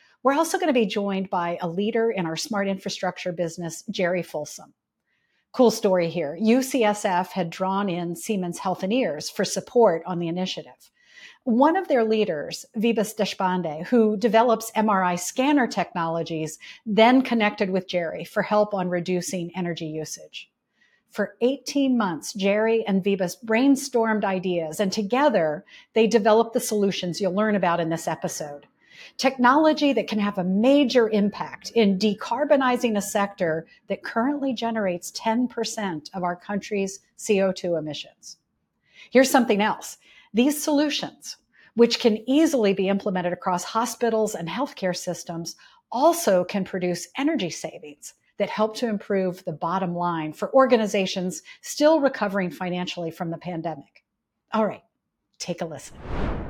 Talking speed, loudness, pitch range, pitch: 140 wpm, -23 LUFS, 180-235 Hz, 205 Hz